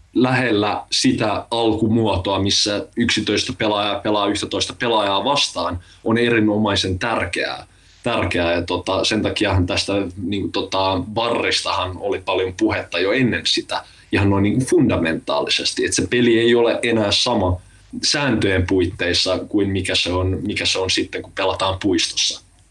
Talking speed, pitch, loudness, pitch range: 130 wpm, 100 Hz, -19 LUFS, 95-110 Hz